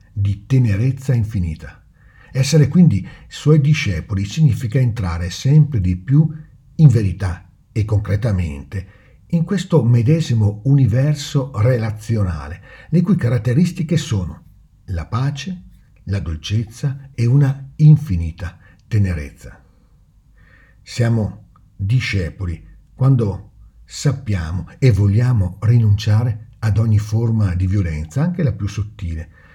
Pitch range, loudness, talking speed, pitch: 95-135 Hz, -18 LUFS, 100 wpm, 110 Hz